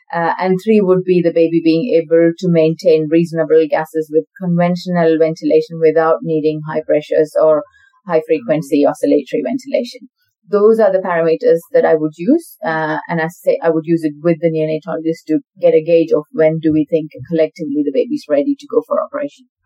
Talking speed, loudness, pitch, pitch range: 185 wpm, -15 LUFS, 165 Hz, 160-220 Hz